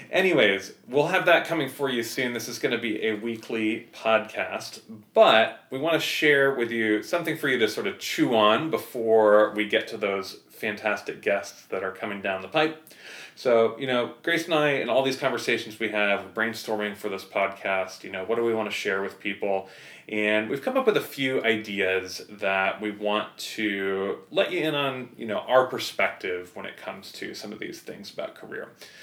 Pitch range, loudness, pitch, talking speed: 105-130 Hz, -25 LUFS, 110 Hz, 205 wpm